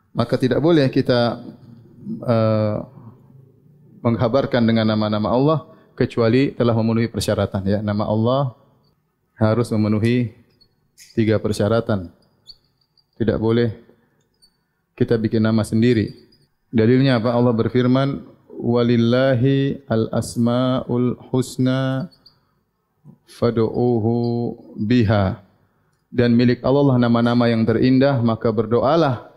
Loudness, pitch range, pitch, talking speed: -19 LUFS, 115-130 Hz, 120 Hz, 90 wpm